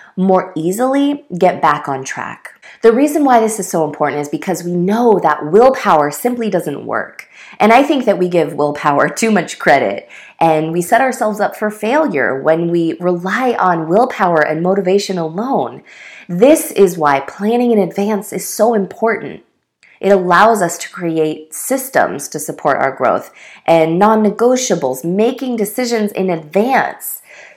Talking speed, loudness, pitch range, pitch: 160 wpm, -14 LUFS, 170-230 Hz, 195 Hz